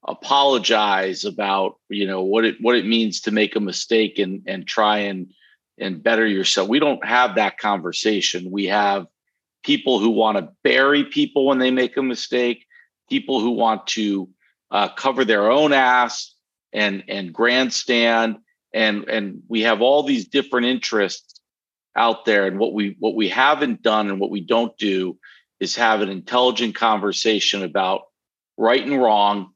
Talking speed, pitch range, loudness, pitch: 165 wpm, 100-125 Hz, -19 LUFS, 110 Hz